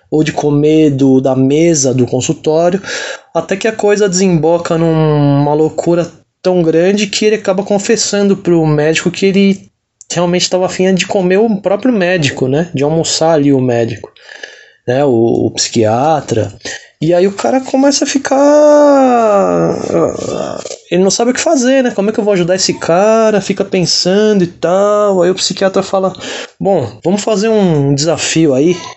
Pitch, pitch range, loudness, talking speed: 180 Hz, 155-205 Hz, -11 LUFS, 165 wpm